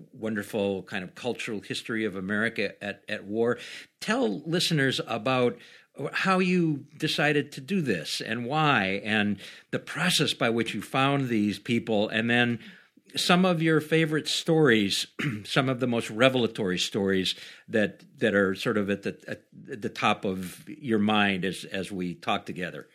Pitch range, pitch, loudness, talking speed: 100-150 Hz, 120 Hz, -27 LUFS, 160 wpm